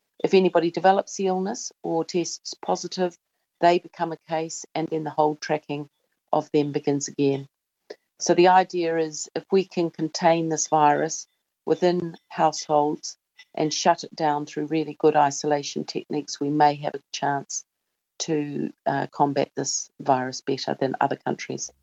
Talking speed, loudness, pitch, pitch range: 155 wpm, -24 LUFS, 160 Hz, 150-170 Hz